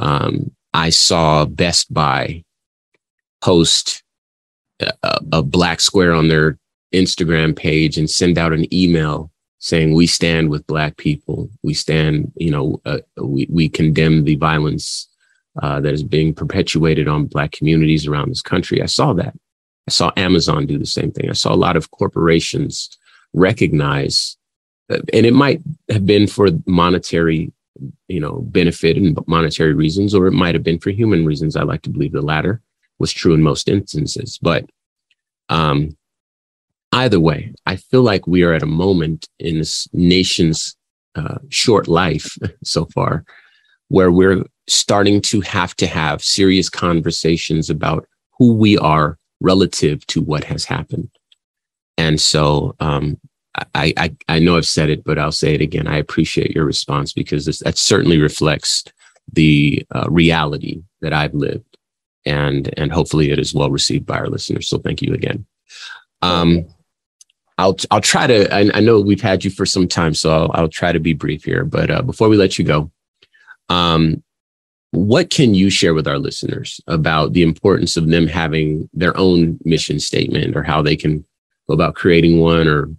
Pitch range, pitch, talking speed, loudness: 75-90 Hz, 80 Hz, 170 wpm, -15 LUFS